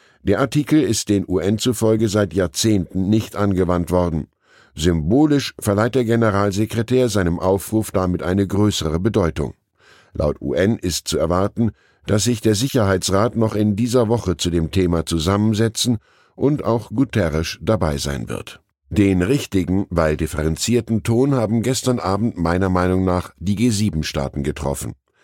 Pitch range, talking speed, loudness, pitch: 90-115 Hz, 140 wpm, -19 LUFS, 100 Hz